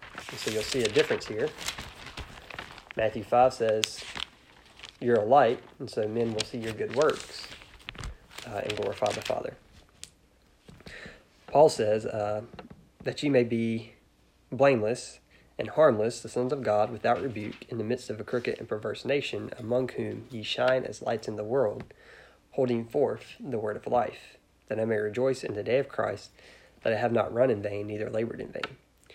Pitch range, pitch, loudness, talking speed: 105-130 Hz, 115 Hz, -29 LUFS, 175 wpm